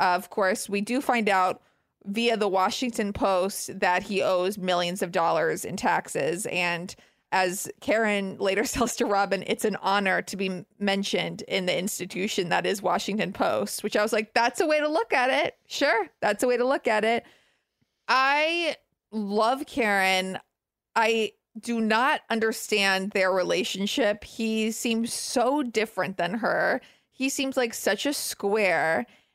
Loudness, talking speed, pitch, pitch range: -25 LUFS, 160 wpm, 210 Hz, 190-235 Hz